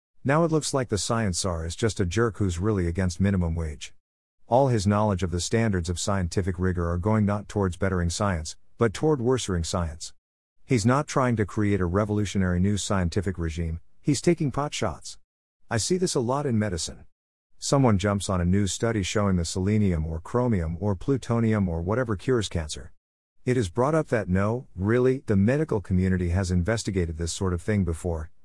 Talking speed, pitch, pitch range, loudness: 190 wpm, 100 Hz, 90-115 Hz, -26 LUFS